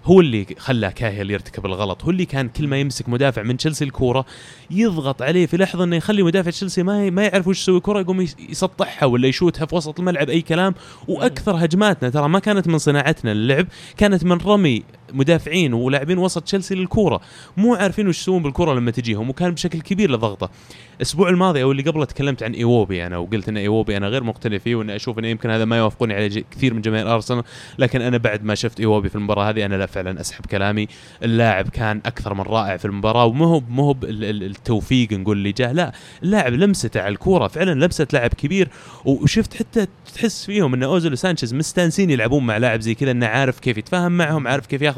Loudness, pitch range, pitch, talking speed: -19 LUFS, 115-180 Hz, 135 Hz, 205 wpm